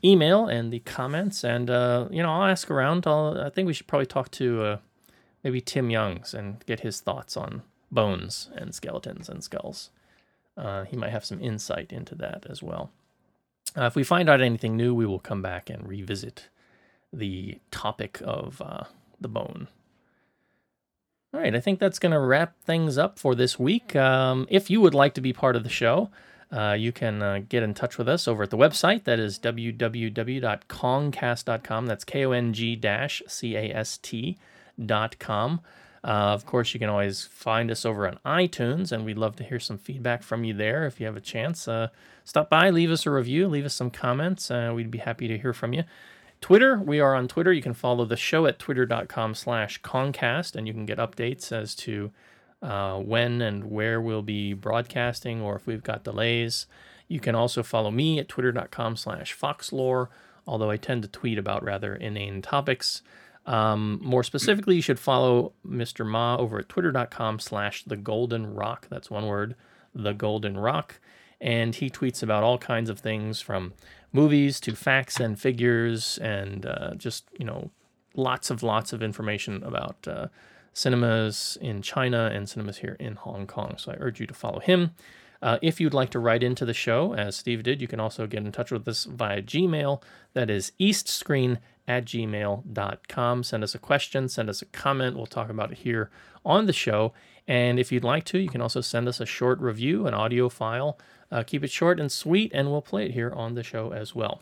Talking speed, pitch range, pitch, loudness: 195 wpm, 110-135 Hz, 120 Hz, -26 LUFS